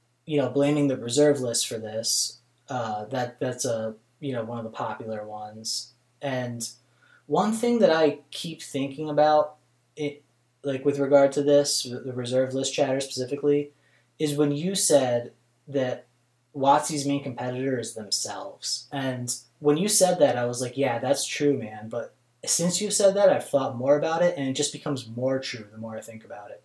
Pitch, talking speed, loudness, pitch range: 135 Hz, 180 wpm, -25 LUFS, 120-145 Hz